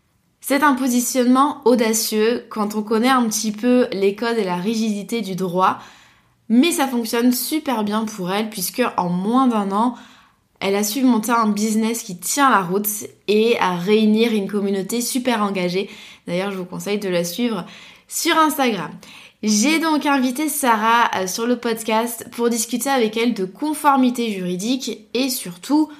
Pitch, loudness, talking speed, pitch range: 225 Hz, -19 LUFS, 165 wpm, 205-250 Hz